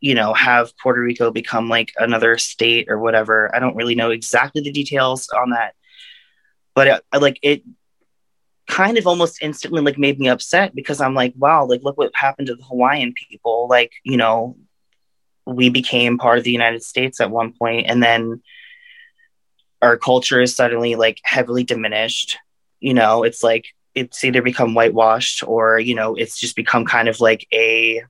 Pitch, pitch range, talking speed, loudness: 120 Hz, 115-135 Hz, 180 wpm, -16 LUFS